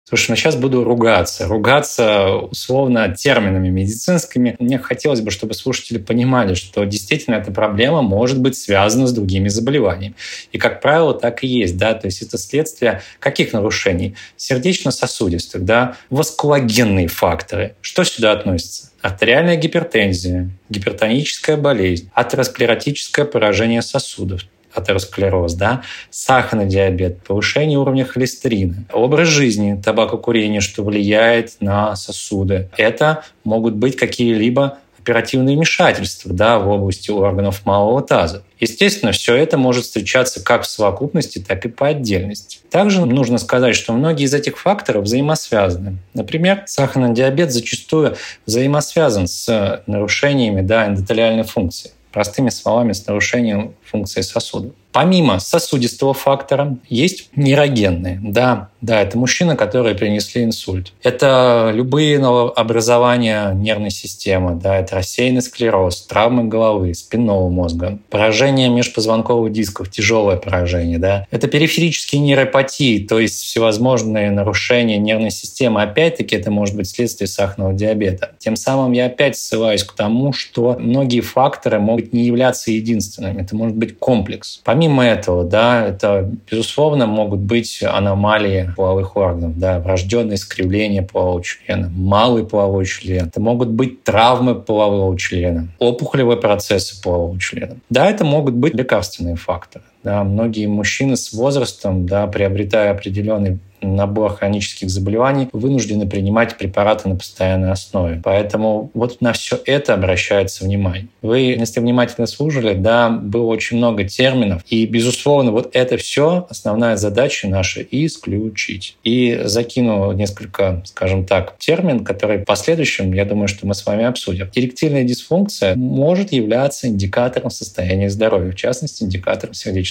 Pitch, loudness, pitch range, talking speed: 110 Hz, -16 LUFS, 100-125 Hz, 130 wpm